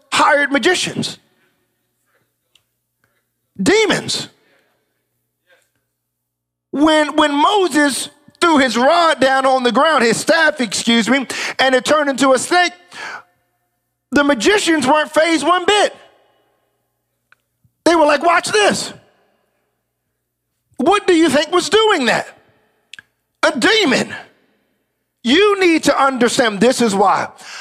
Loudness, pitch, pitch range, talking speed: -14 LUFS, 295 Hz, 255-330 Hz, 110 wpm